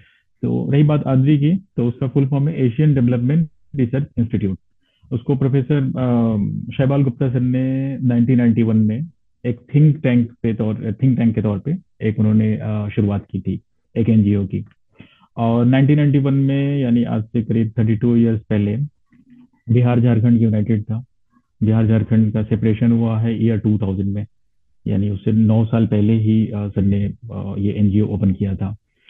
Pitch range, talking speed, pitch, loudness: 110-130 Hz, 155 wpm, 115 Hz, -18 LUFS